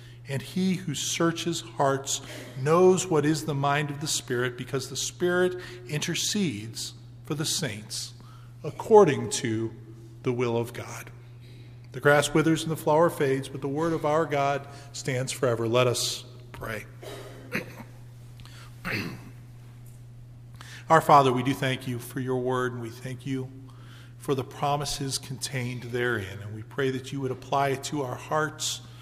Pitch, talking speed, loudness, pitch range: 130 Hz, 150 wpm, -27 LUFS, 120-145 Hz